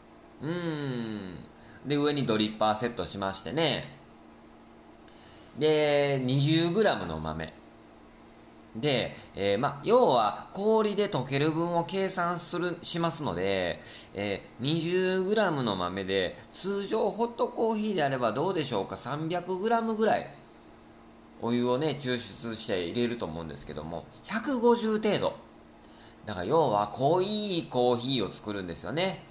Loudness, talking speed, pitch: -28 LUFS, 235 characters per minute, 145 Hz